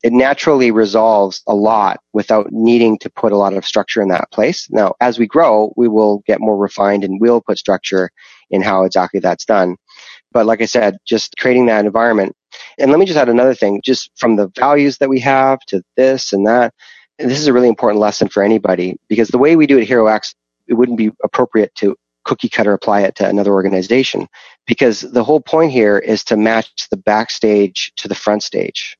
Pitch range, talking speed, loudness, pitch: 100-125 Hz, 210 wpm, -13 LUFS, 110 Hz